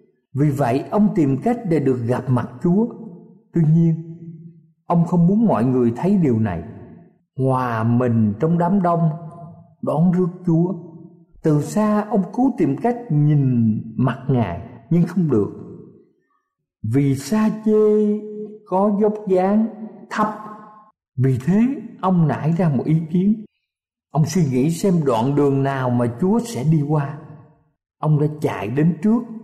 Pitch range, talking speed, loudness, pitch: 140-205 Hz, 145 wpm, -19 LUFS, 170 Hz